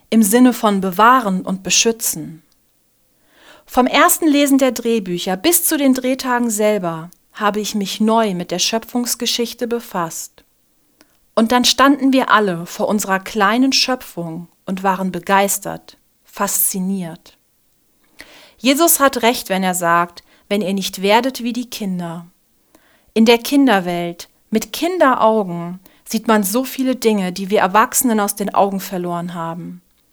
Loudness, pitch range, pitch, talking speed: -16 LUFS, 190-245 Hz, 215 Hz, 135 wpm